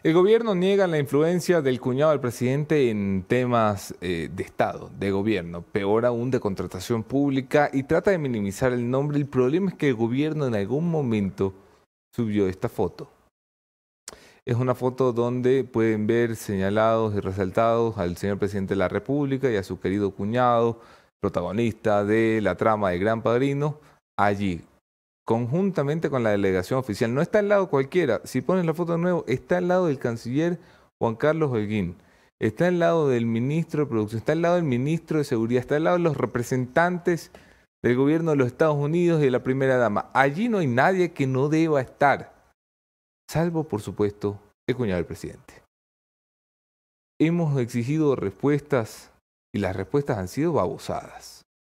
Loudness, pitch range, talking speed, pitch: -24 LUFS, 105-150 Hz, 170 wpm, 125 Hz